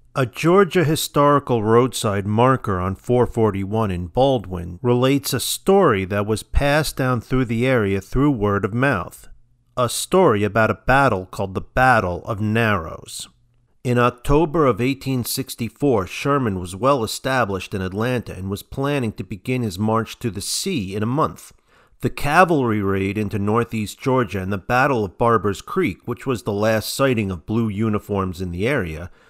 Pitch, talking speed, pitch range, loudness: 115 Hz, 160 wpm, 100-130 Hz, -20 LUFS